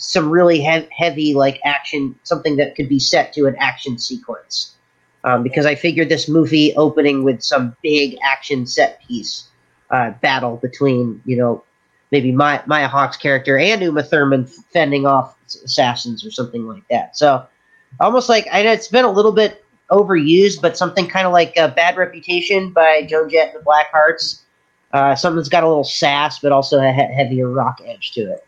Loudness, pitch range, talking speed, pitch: -15 LUFS, 135-170 Hz, 190 wpm, 150 Hz